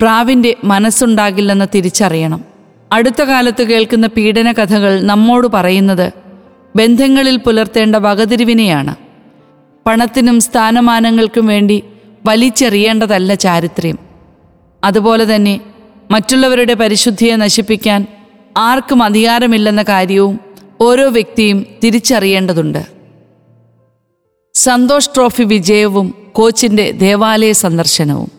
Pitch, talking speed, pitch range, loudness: 215 Hz, 75 wpm, 195-230 Hz, -10 LUFS